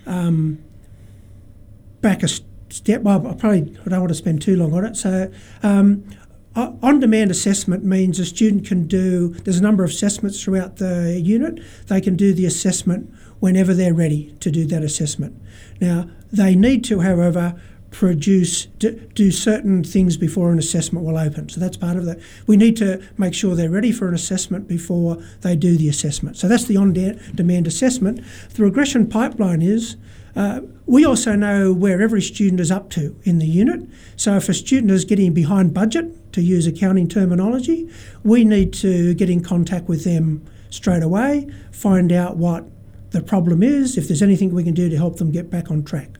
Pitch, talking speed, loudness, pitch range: 185 Hz, 190 wpm, -18 LUFS, 170-205 Hz